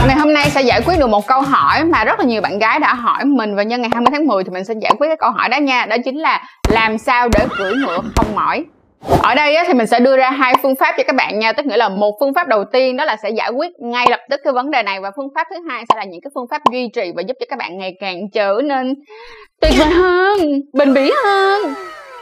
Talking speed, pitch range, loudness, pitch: 290 wpm, 230-310 Hz, -15 LUFS, 265 Hz